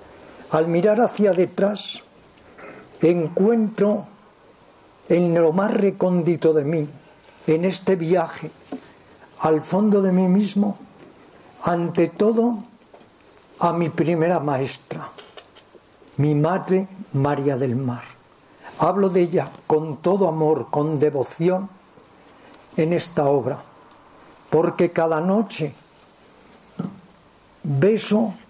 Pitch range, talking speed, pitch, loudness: 155-200 Hz, 95 wpm, 175 Hz, -21 LUFS